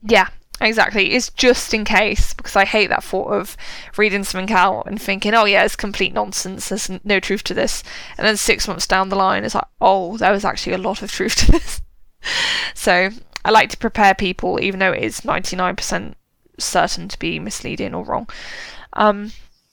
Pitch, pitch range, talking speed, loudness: 200 Hz, 190-220 Hz, 195 wpm, -18 LUFS